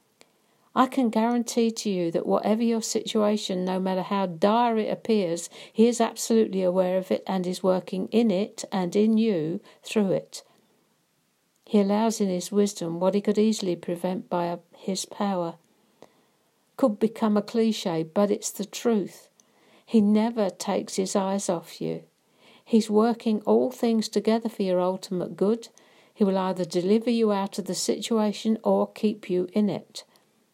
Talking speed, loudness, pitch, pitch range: 165 wpm, -25 LUFS, 205 Hz, 185-225 Hz